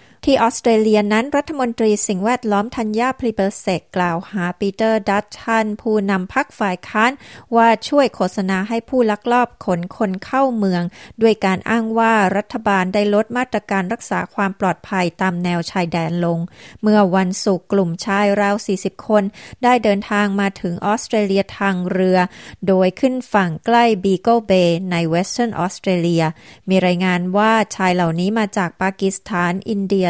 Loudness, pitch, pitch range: -18 LUFS, 200 Hz, 185-225 Hz